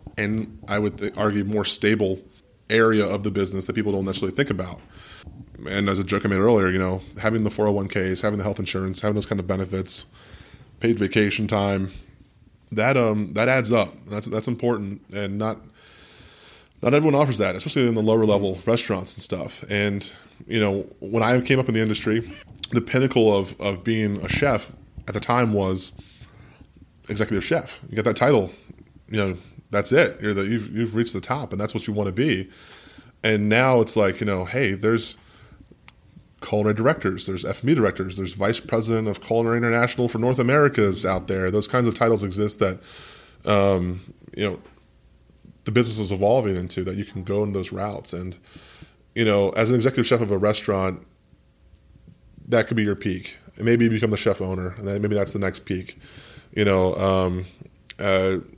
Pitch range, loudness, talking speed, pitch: 95-115 Hz, -23 LUFS, 190 wpm, 105 Hz